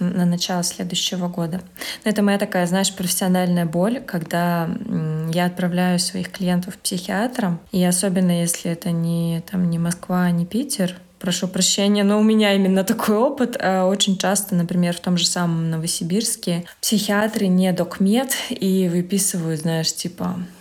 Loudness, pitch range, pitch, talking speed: -20 LUFS, 175-200 Hz, 180 Hz, 150 wpm